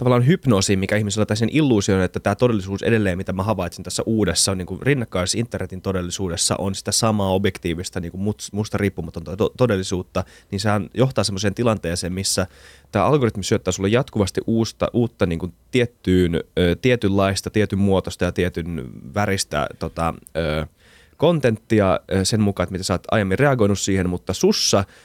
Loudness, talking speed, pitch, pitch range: -21 LUFS, 165 wpm, 100 Hz, 90-110 Hz